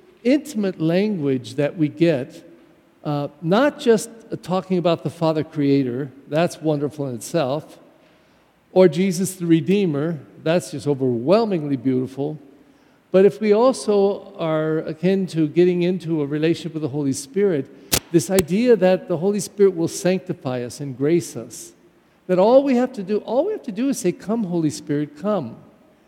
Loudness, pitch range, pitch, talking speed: -20 LUFS, 145-195 Hz, 170 Hz, 160 wpm